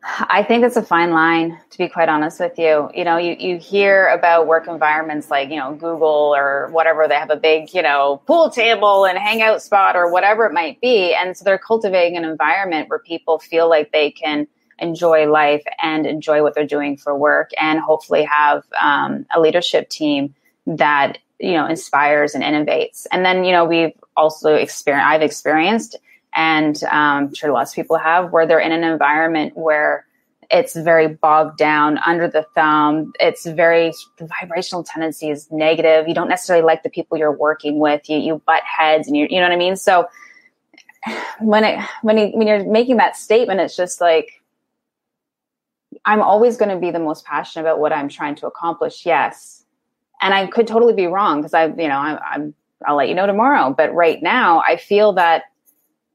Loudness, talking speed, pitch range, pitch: -16 LUFS, 195 wpm, 155-195 Hz, 165 Hz